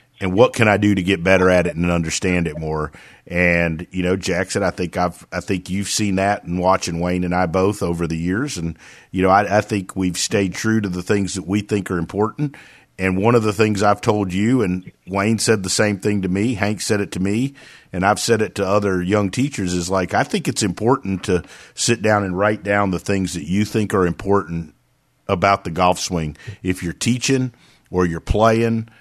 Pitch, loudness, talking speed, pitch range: 95 Hz, -19 LUFS, 230 wpm, 90-105 Hz